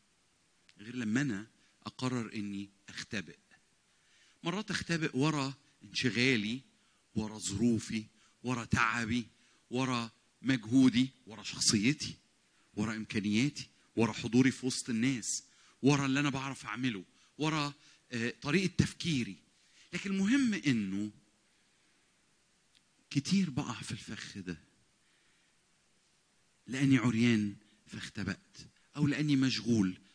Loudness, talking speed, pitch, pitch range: -33 LUFS, 95 wpm, 125 Hz, 110-140 Hz